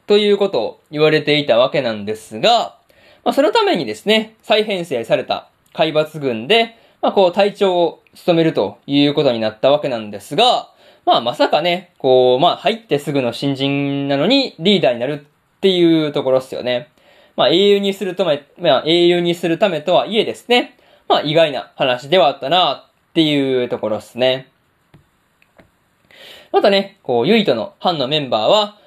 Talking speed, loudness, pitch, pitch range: 335 characters per minute, -16 LUFS, 165 Hz, 140-205 Hz